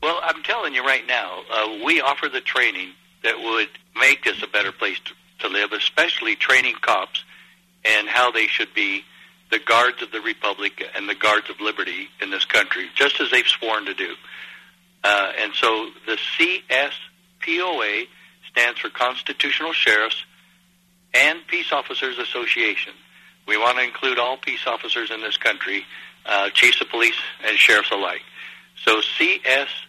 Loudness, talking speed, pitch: -19 LUFS, 160 wpm, 335 Hz